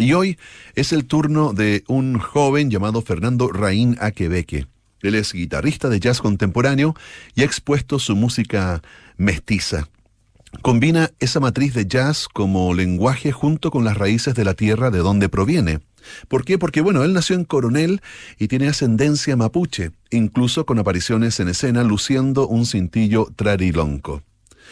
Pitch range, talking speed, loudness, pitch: 100-140 Hz, 150 wpm, -19 LUFS, 115 Hz